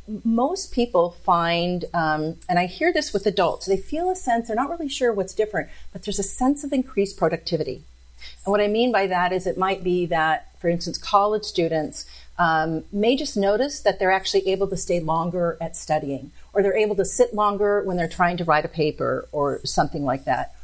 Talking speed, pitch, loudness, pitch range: 210 wpm, 190 Hz, -23 LUFS, 165-210 Hz